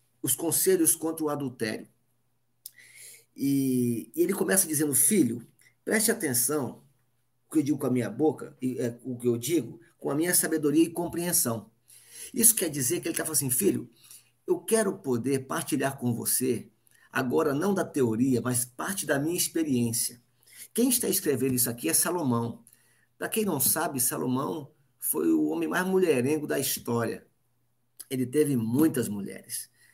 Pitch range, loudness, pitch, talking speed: 120-160 Hz, -26 LUFS, 135 Hz, 160 wpm